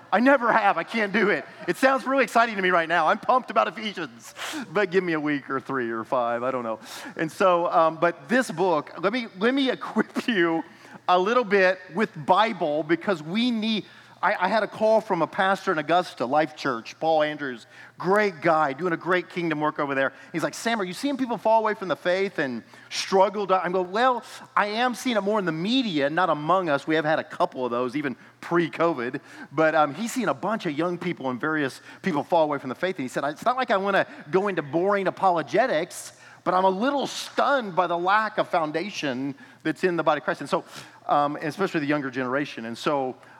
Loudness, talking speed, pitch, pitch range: -24 LUFS, 230 wpm, 180 Hz, 155-210 Hz